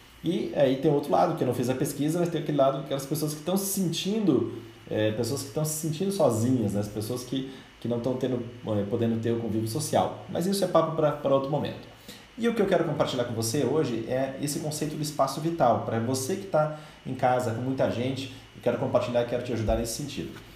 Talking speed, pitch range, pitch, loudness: 240 wpm, 120-155 Hz, 135 Hz, -27 LUFS